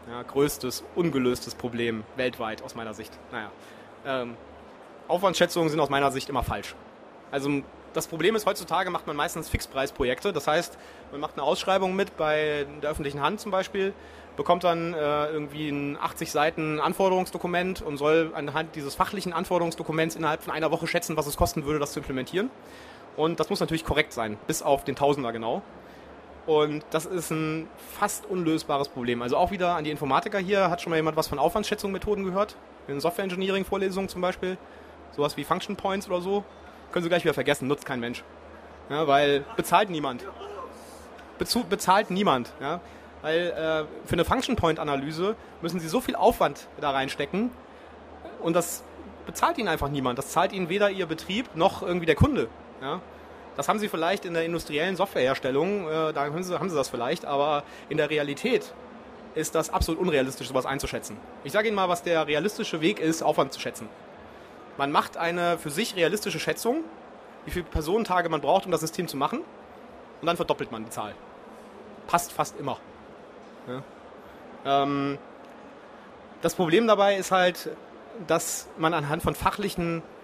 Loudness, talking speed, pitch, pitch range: -27 LUFS, 165 wpm, 160 Hz, 145-185 Hz